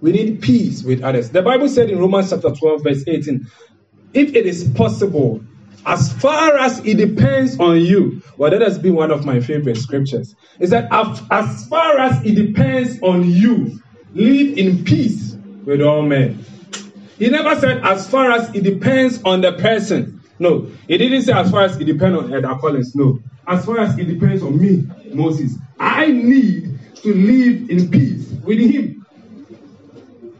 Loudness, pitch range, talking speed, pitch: -15 LUFS, 145-230 Hz, 175 wpm, 185 Hz